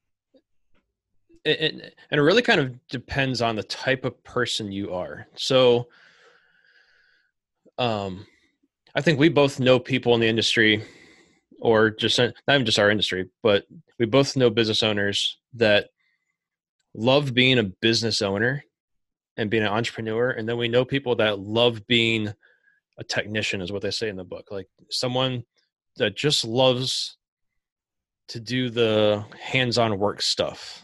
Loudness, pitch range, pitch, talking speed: -22 LUFS, 110-130 Hz, 120 Hz, 145 wpm